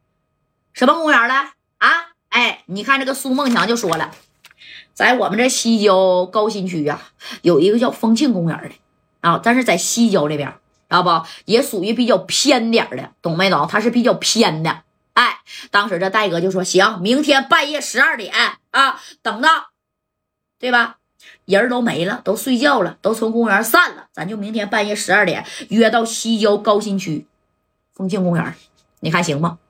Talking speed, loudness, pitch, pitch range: 250 characters per minute, -16 LUFS, 225 Hz, 190-260 Hz